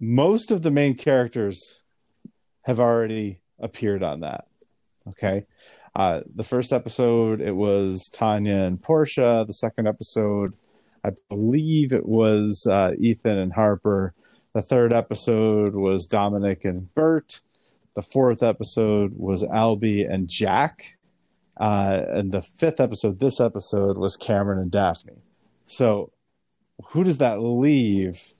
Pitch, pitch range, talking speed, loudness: 110 Hz, 100-120 Hz, 130 wpm, -22 LUFS